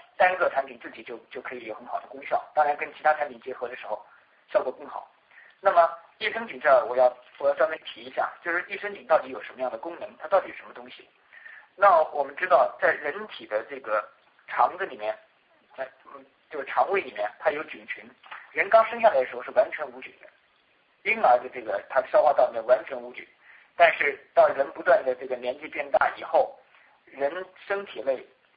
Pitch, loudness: 170 Hz, -25 LUFS